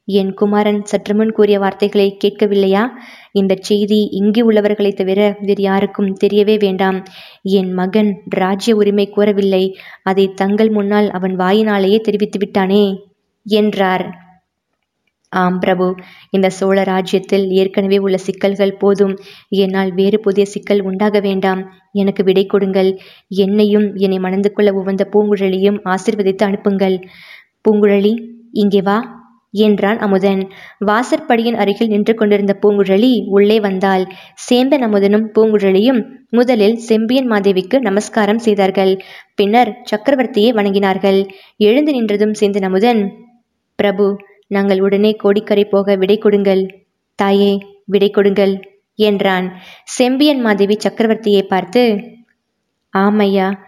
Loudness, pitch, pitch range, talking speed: -14 LUFS, 200 Hz, 195-210 Hz, 110 wpm